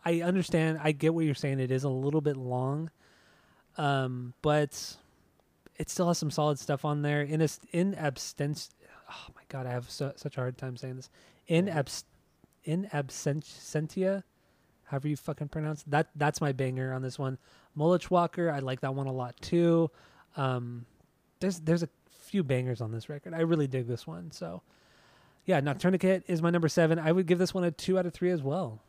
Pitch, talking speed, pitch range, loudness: 150 Hz, 200 wpm, 130-170 Hz, -31 LUFS